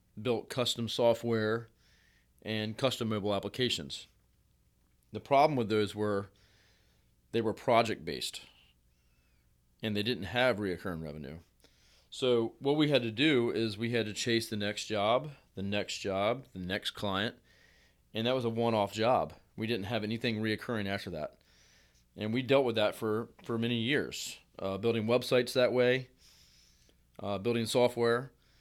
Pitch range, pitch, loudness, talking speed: 90-120 Hz, 110 Hz, -32 LUFS, 150 wpm